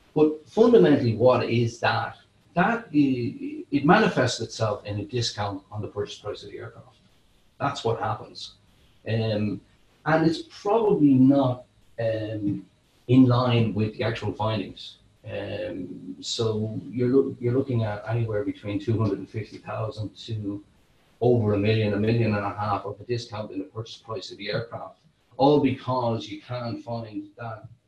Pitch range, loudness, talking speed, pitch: 105-130 Hz, -25 LUFS, 155 wpm, 115 Hz